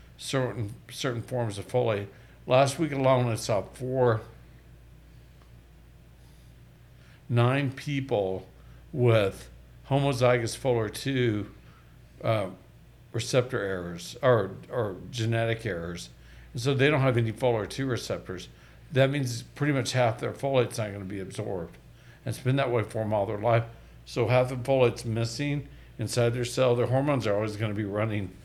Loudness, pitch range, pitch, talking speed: -28 LUFS, 105-130 Hz, 120 Hz, 150 wpm